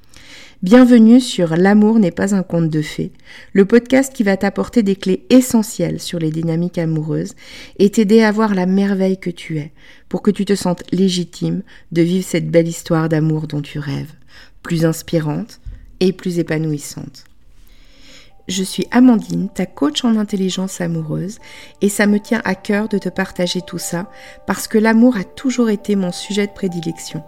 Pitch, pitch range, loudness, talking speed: 185 Hz, 165-205 Hz, -16 LUFS, 175 wpm